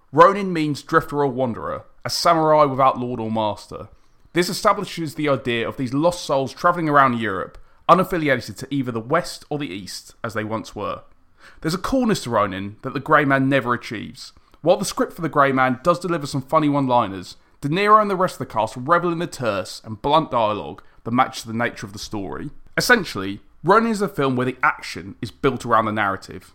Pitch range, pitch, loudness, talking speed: 120-170 Hz, 140 Hz, -20 LUFS, 210 wpm